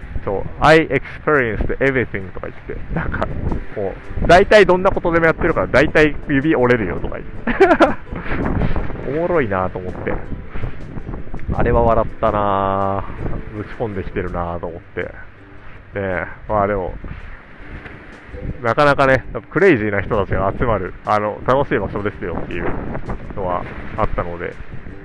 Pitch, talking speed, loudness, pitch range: 105 Hz, 310 characters per minute, -18 LUFS, 95-135 Hz